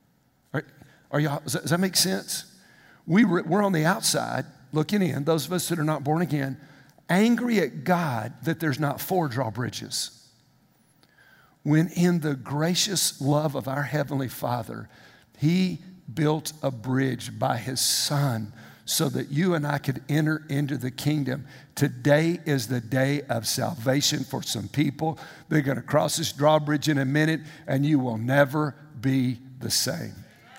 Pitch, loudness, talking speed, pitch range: 150 Hz, -25 LUFS, 155 wpm, 135-160 Hz